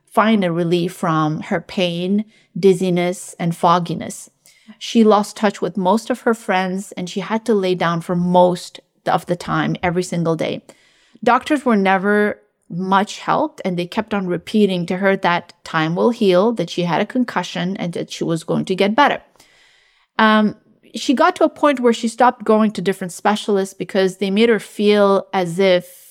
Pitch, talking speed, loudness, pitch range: 195 Hz, 185 wpm, -18 LUFS, 180-220 Hz